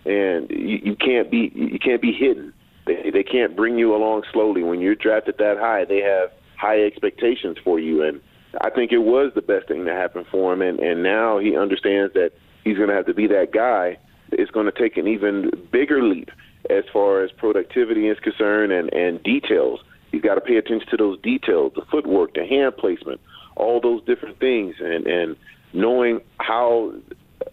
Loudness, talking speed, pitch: -20 LUFS, 200 wpm, 125 Hz